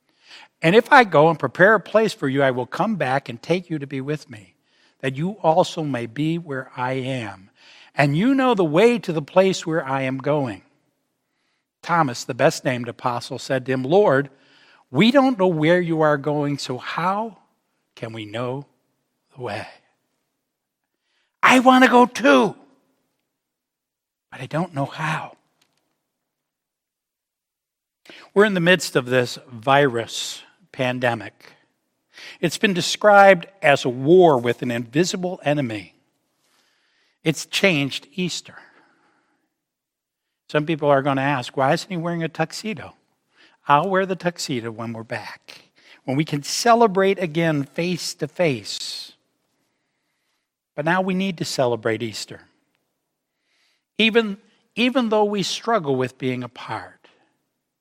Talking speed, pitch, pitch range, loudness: 140 wpm, 150 Hz, 130-185 Hz, -20 LUFS